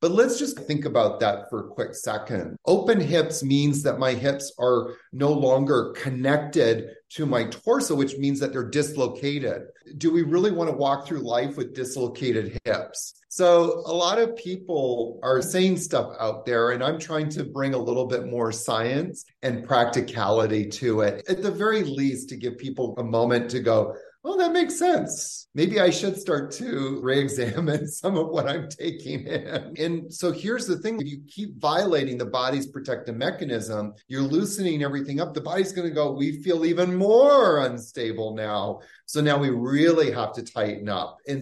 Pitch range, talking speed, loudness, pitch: 125-170 Hz, 185 wpm, -24 LUFS, 140 Hz